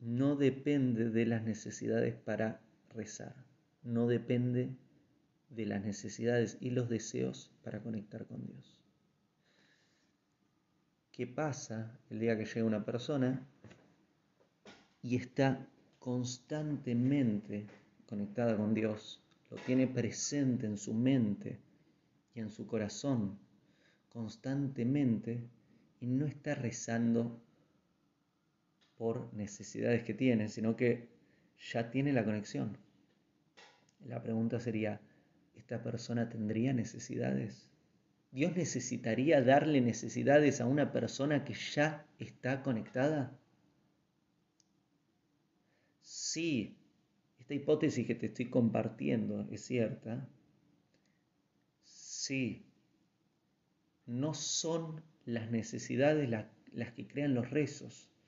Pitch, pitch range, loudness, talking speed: 120 Hz, 110-140 Hz, -36 LUFS, 100 wpm